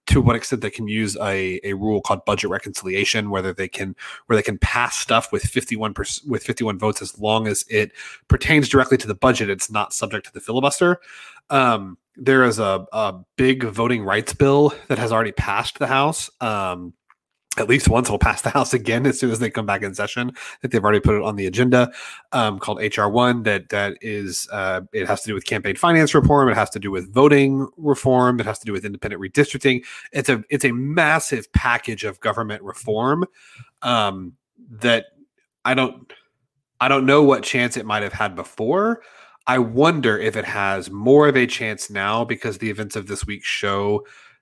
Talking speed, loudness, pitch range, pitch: 205 wpm, -20 LUFS, 105-135 Hz, 115 Hz